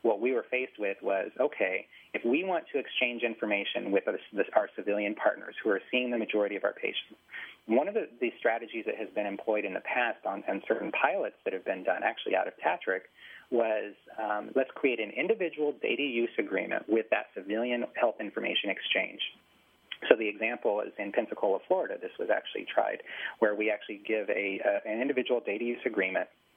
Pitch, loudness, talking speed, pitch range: 120 Hz, -31 LUFS, 200 wpm, 105-145 Hz